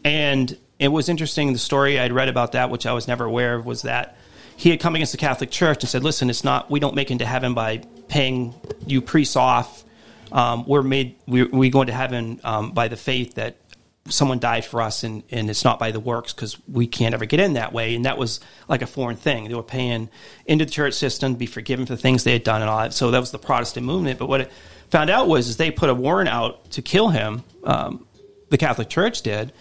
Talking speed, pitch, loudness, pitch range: 255 wpm, 125 Hz, -21 LUFS, 120-140 Hz